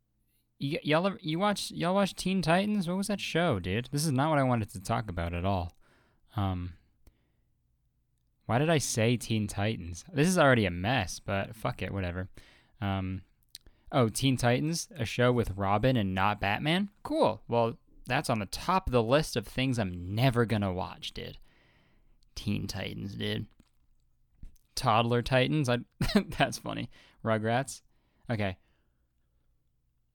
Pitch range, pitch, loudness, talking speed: 100-140 Hz, 115 Hz, -30 LUFS, 155 wpm